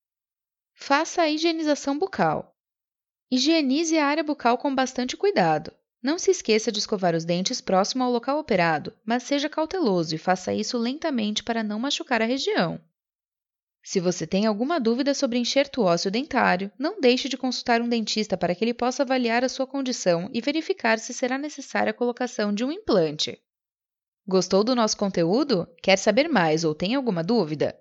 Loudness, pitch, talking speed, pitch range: -24 LUFS, 240 Hz, 170 wpm, 200-280 Hz